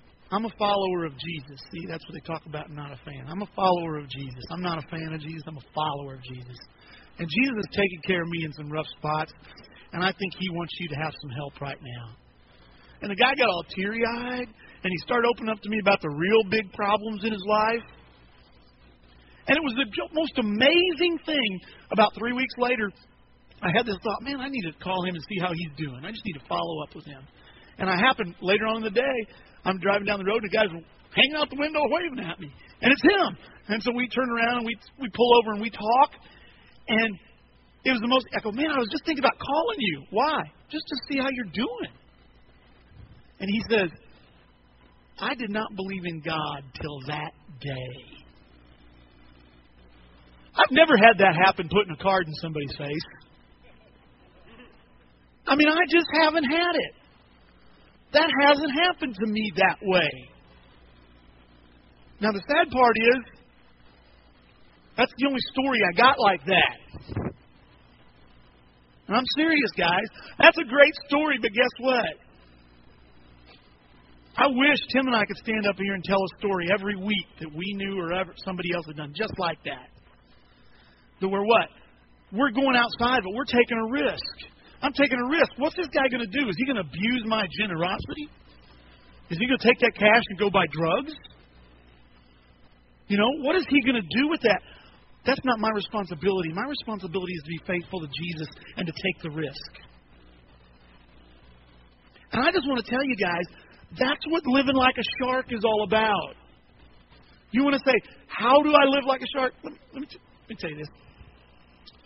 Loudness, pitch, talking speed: -24 LUFS, 190 Hz, 195 wpm